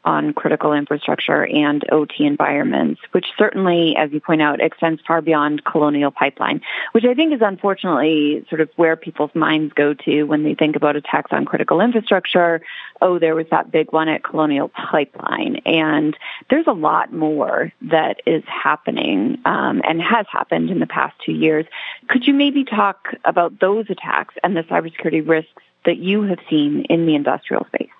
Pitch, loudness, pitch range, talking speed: 160 Hz, -18 LUFS, 150-195 Hz, 175 wpm